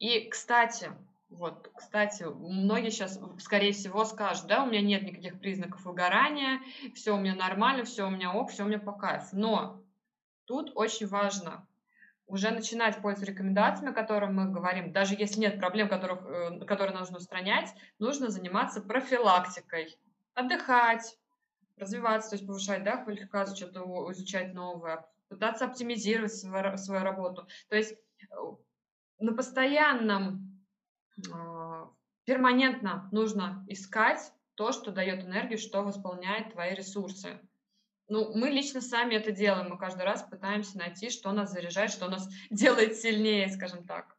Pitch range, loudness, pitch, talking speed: 190-225 Hz, -31 LUFS, 205 Hz, 140 wpm